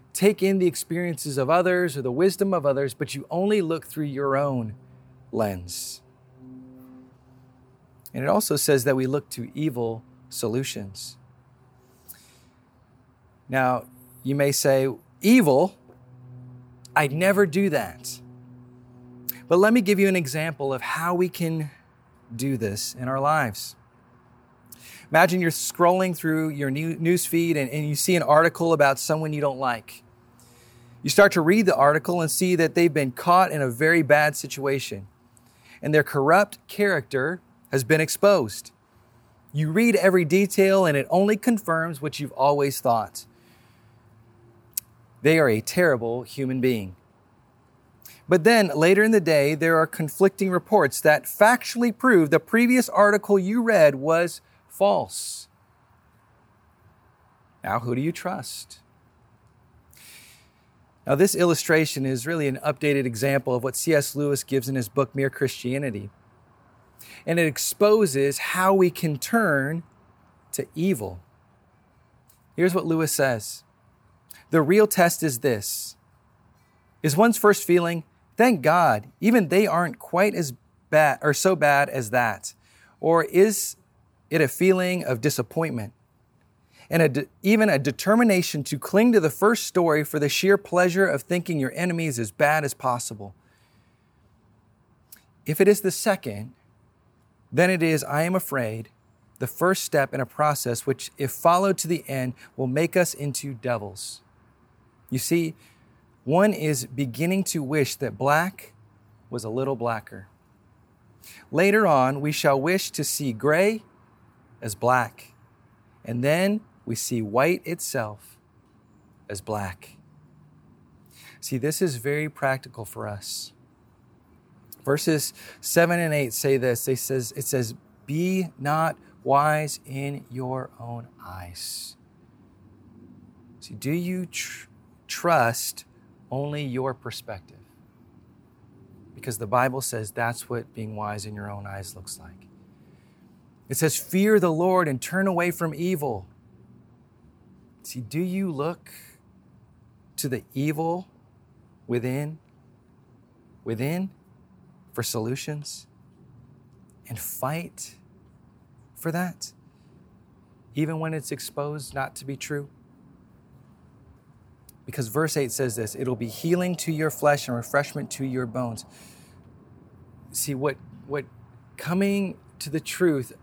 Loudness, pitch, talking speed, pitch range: -23 LUFS, 135 Hz, 135 wpm, 120-165 Hz